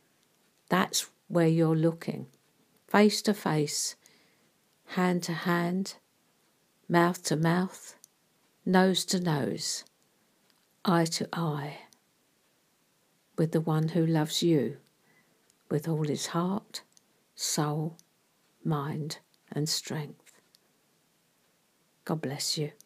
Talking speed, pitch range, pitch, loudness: 95 wpm, 155-180 Hz, 165 Hz, -29 LUFS